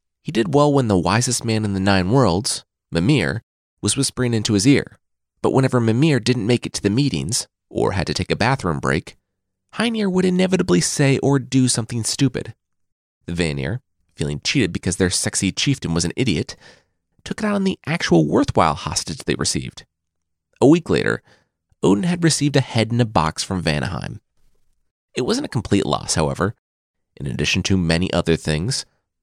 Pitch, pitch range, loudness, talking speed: 110 Hz, 90-135 Hz, -19 LUFS, 175 wpm